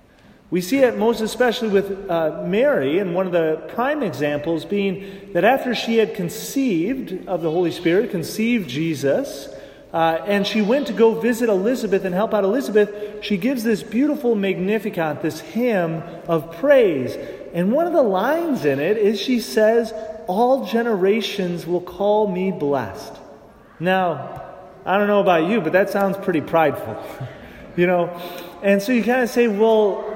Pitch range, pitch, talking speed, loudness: 175-230 Hz, 200 Hz, 165 wpm, -20 LUFS